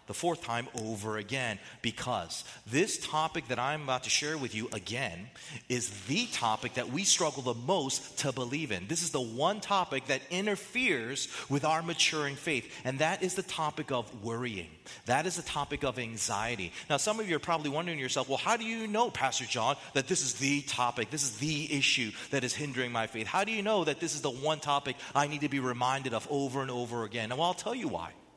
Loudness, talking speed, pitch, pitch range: -32 LUFS, 225 wpm, 140 Hz, 125-160 Hz